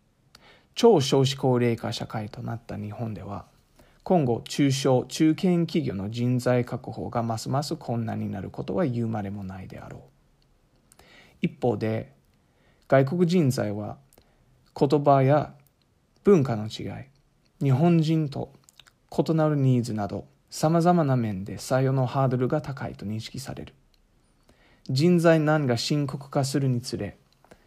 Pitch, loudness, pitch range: 130 Hz, -25 LUFS, 115-150 Hz